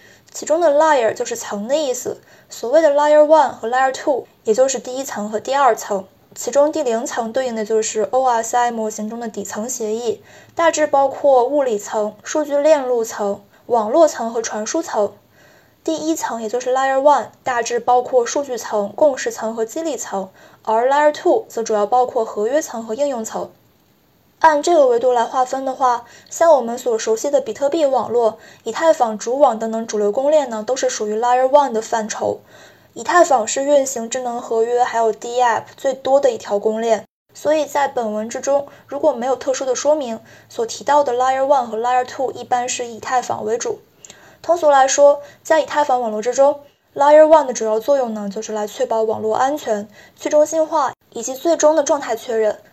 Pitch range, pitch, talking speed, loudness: 225-290 Hz, 255 Hz, 340 characters per minute, -17 LUFS